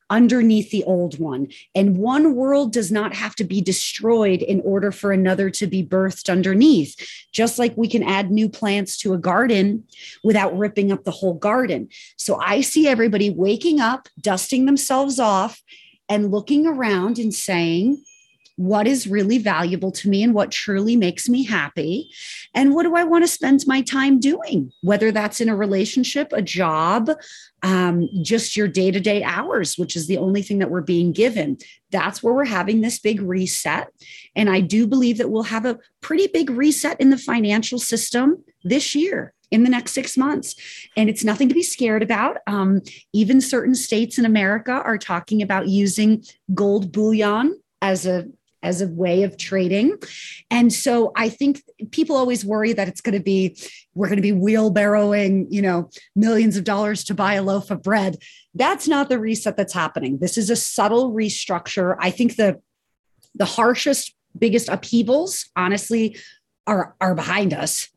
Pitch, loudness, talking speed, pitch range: 215 Hz, -19 LUFS, 180 wpm, 195-245 Hz